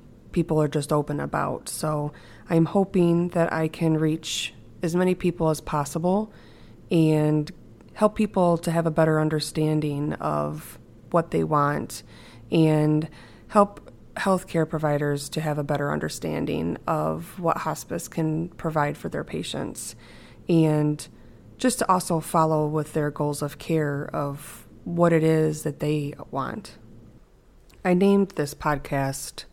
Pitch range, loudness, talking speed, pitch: 145-165 Hz, -25 LUFS, 135 wpm, 155 Hz